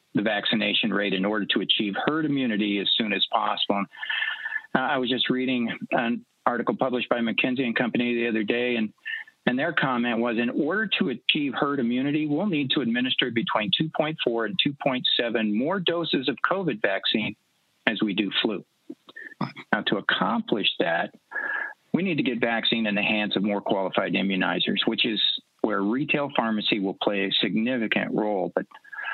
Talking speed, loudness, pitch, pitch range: 170 wpm, -25 LUFS, 130 Hz, 110-170 Hz